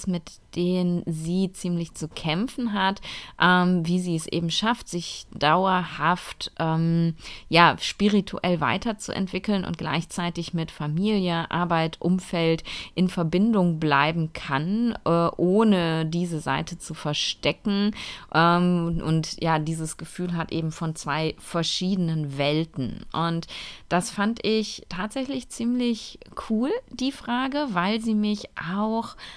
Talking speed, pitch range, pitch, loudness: 120 wpm, 165-205 Hz, 175 Hz, -25 LUFS